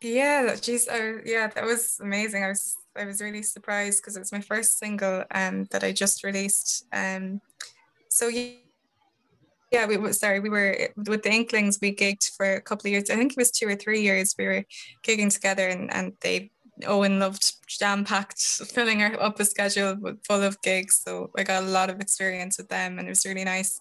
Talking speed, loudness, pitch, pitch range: 205 wpm, -25 LUFS, 200 Hz, 190-215 Hz